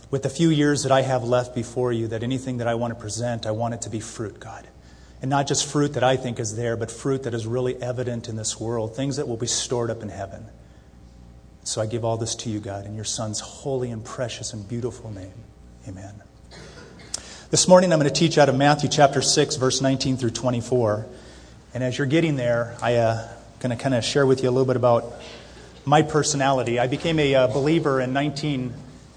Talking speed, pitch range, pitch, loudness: 230 wpm, 110-135 Hz, 120 Hz, -23 LUFS